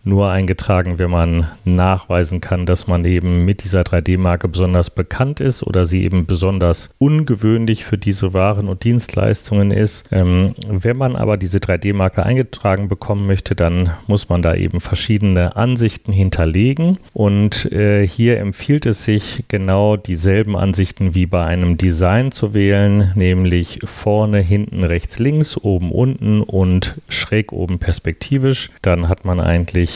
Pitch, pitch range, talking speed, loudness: 95 Hz, 90-105 Hz, 145 wpm, -16 LUFS